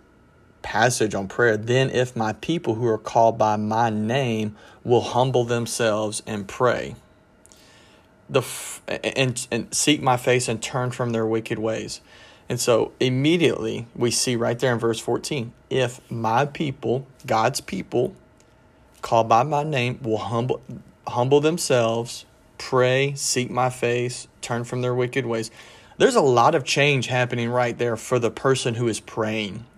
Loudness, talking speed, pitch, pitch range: -22 LUFS, 155 wpm, 120 Hz, 115-130 Hz